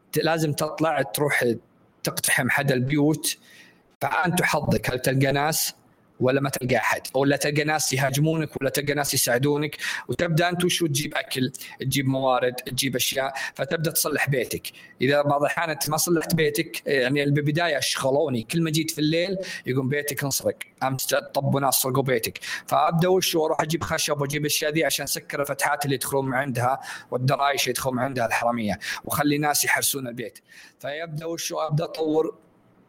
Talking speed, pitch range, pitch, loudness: 150 wpm, 135-155 Hz, 145 Hz, -24 LUFS